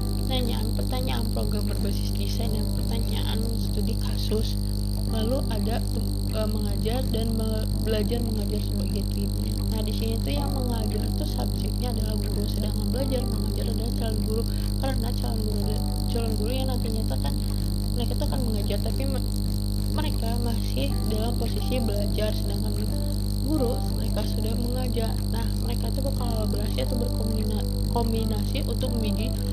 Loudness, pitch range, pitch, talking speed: -27 LUFS, 100-105 Hz, 100 Hz, 140 wpm